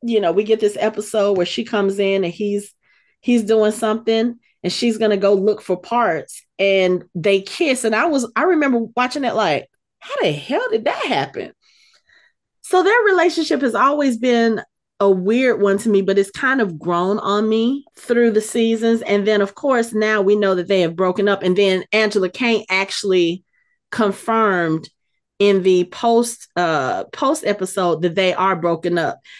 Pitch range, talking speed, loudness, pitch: 195-235 Hz, 180 wpm, -18 LUFS, 215 Hz